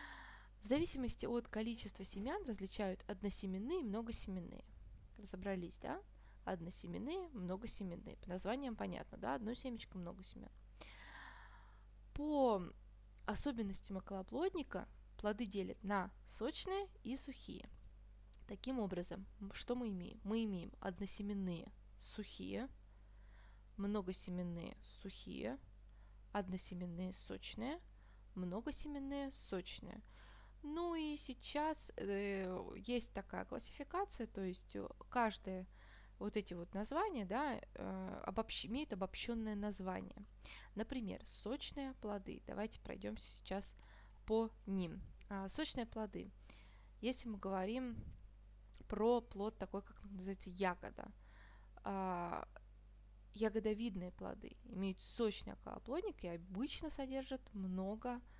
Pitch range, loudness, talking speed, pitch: 185-235 Hz, -45 LUFS, 95 wpm, 200 Hz